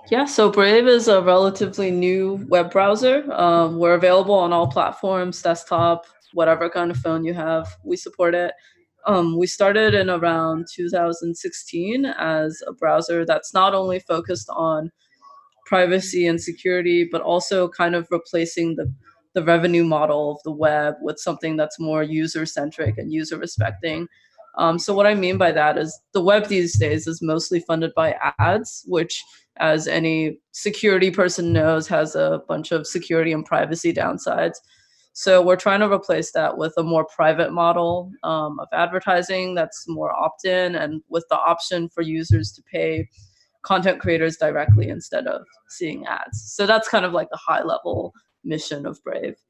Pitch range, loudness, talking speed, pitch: 160-185 Hz, -20 LUFS, 165 wpm, 170 Hz